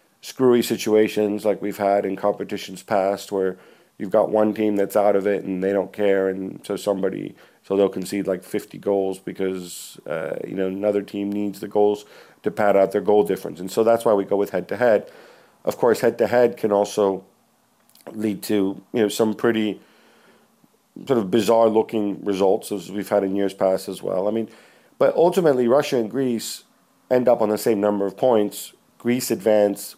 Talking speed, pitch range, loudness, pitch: 195 wpm, 100-110 Hz, -21 LUFS, 105 Hz